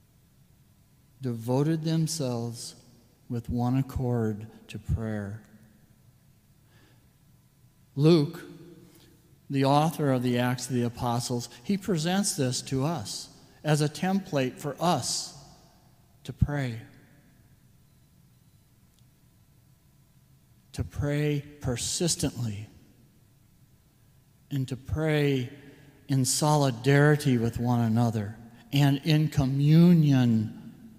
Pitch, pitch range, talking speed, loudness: 135 Hz, 120-145 Hz, 80 wpm, -27 LUFS